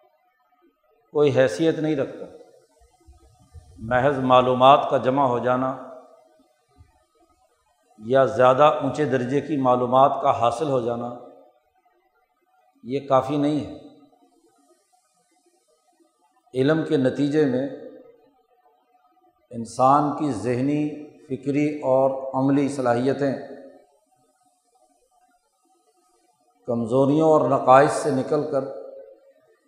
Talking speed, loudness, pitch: 85 wpm, -21 LUFS, 145 Hz